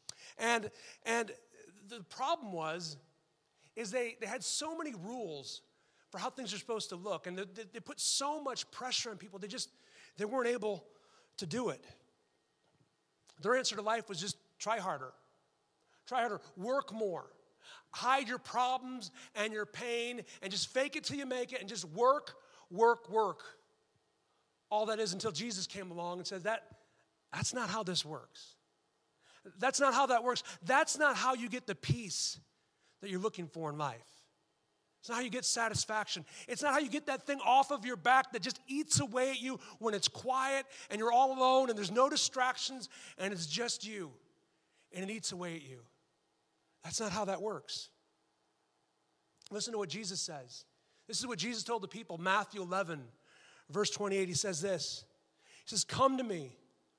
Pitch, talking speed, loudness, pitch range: 220 Hz, 180 wpm, -36 LUFS, 190-255 Hz